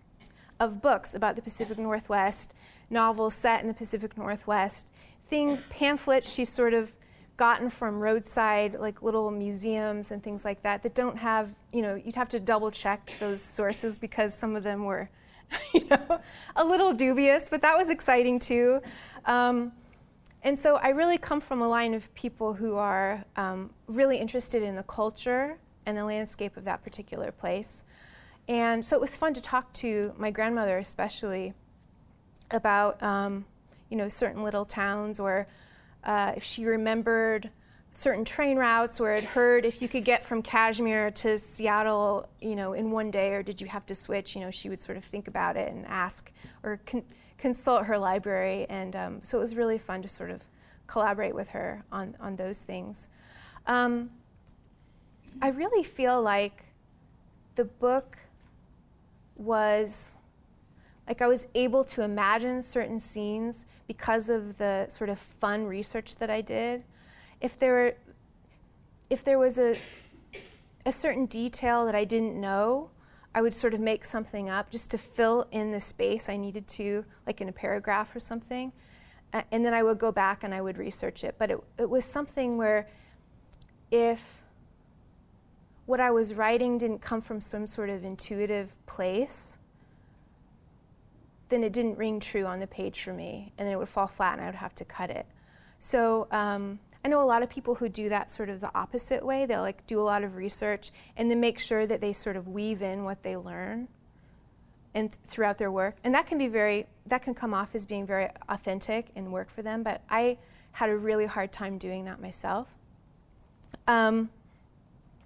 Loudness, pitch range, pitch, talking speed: -29 LUFS, 205-240 Hz, 220 Hz, 180 wpm